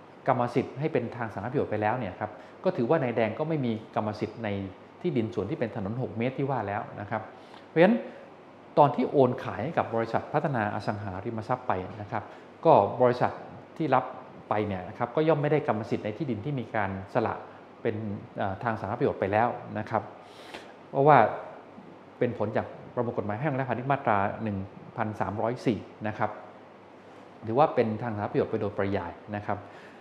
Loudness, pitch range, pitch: -28 LUFS, 105-120 Hz, 110 Hz